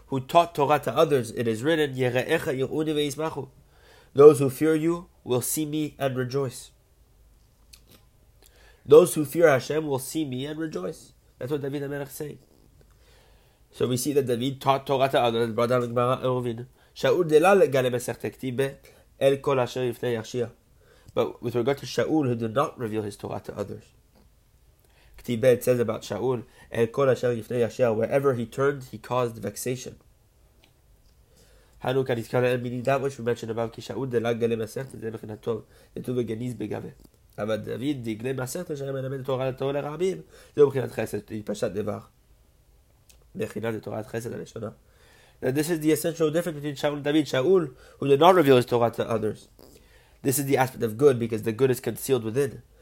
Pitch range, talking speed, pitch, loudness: 120-145 Hz, 160 wpm, 130 Hz, -25 LUFS